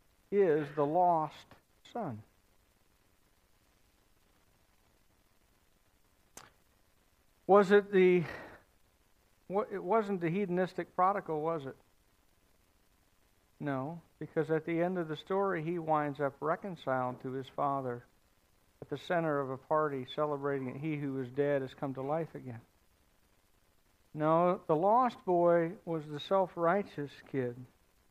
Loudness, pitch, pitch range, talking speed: -32 LUFS, 145 Hz, 105-170 Hz, 120 wpm